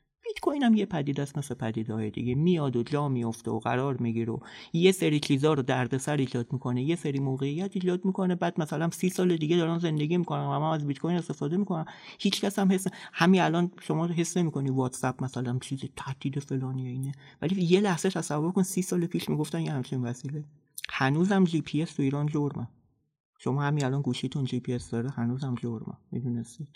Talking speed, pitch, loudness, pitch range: 195 wpm, 145 Hz, -29 LUFS, 130-170 Hz